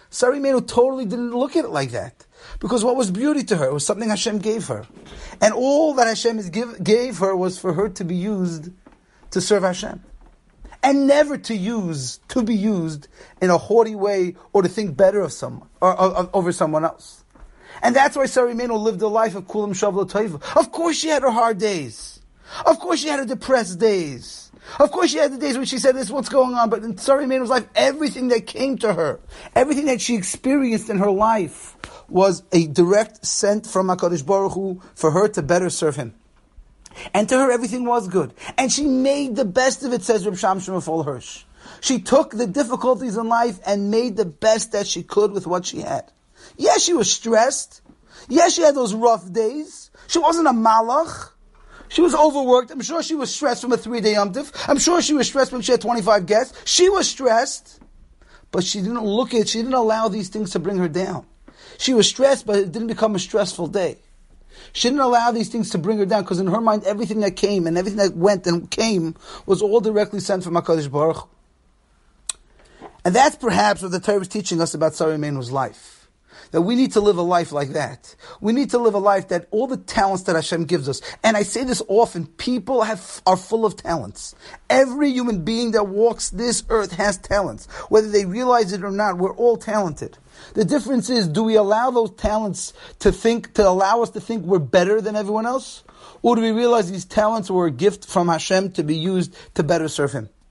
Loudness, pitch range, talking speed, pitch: -20 LUFS, 185-245 Hz, 215 wpm, 215 Hz